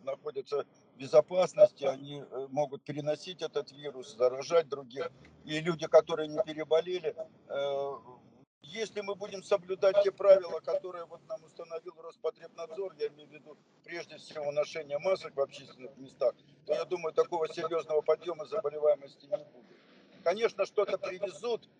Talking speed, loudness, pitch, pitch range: 140 wpm, -32 LUFS, 165 Hz, 150-195 Hz